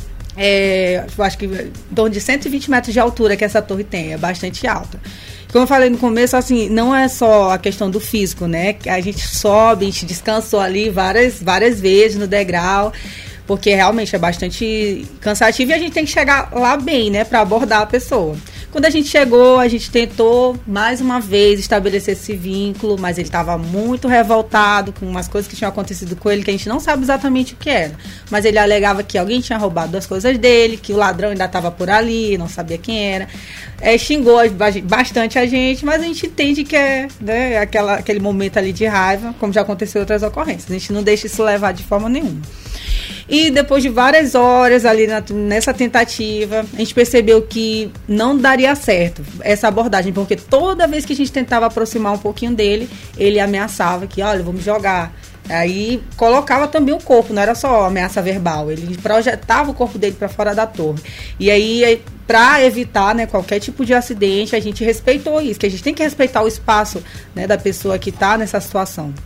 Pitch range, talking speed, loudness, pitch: 195-245 Hz, 205 wpm, -15 LUFS, 215 Hz